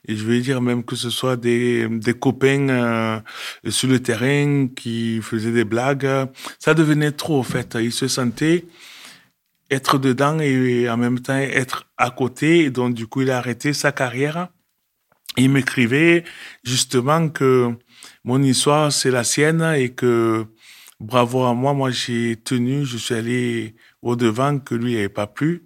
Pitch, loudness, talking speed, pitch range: 130 Hz, -19 LUFS, 165 wpm, 120-140 Hz